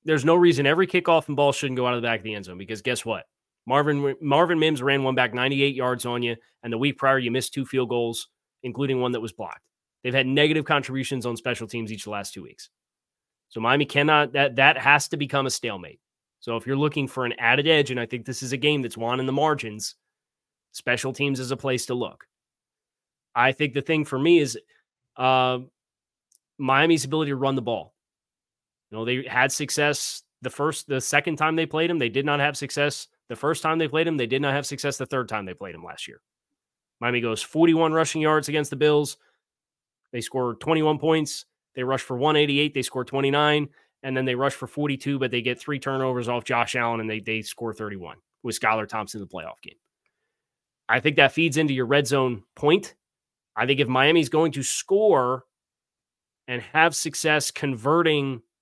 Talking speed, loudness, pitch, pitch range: 215 wpm, -23 LUFS, 135 Hz, 120-150 Hz